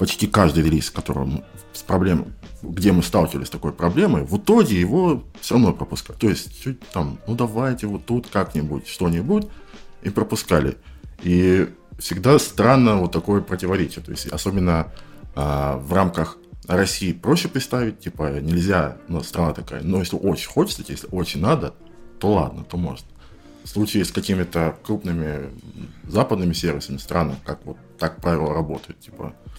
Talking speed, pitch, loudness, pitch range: 150 wpm, 90 Hz, -21 LUFS, 80-105 Hz